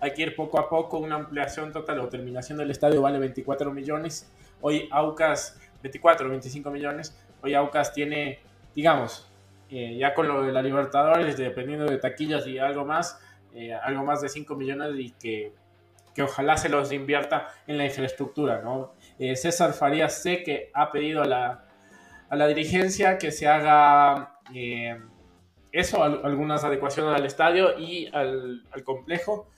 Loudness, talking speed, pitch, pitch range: -25 LUFS, 165 wpm, 145 Hz, 130-150 Hz